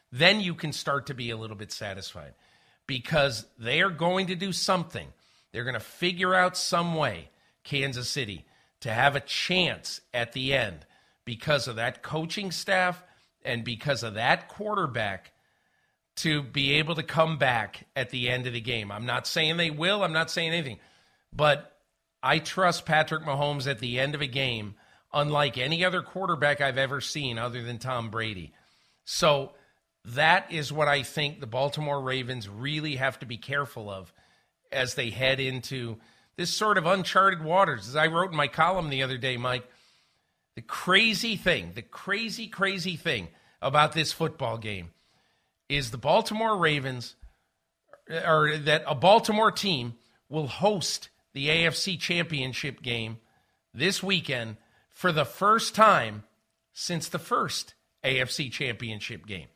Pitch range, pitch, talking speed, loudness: 120-170 Hz, 140 Hz, 160 wpm, -27 LUFS